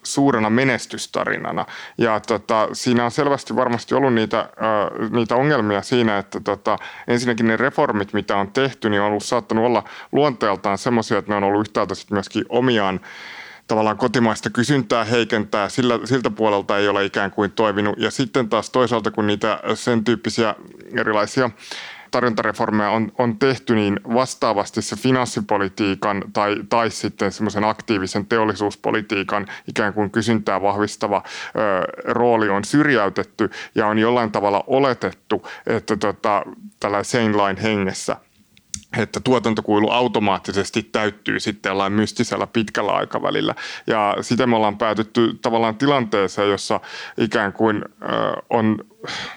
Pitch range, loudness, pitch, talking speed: 105-120 Hz, -20 LUFS, 110 Hz, 135 wpm